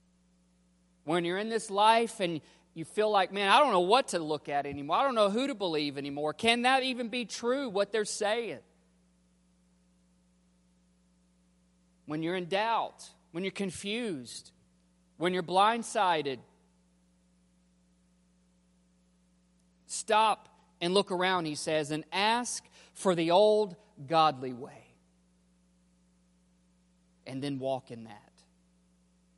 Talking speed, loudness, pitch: 125 wpm, -29 LUFS, 140 Hz